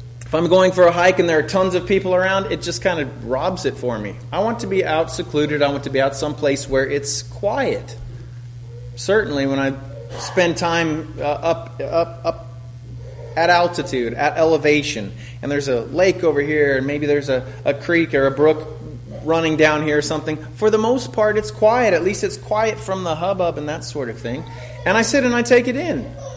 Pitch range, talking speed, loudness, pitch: 130-175 Hz, 215 wpm, -19 LUFS, 150 Hz